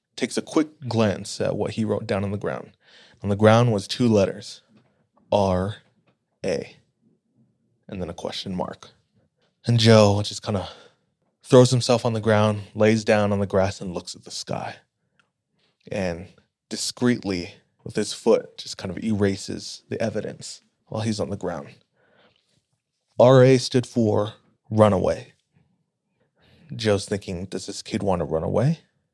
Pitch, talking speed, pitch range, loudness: 105 Hz, 155 wpm, 100-115 Hz, -22 LUFS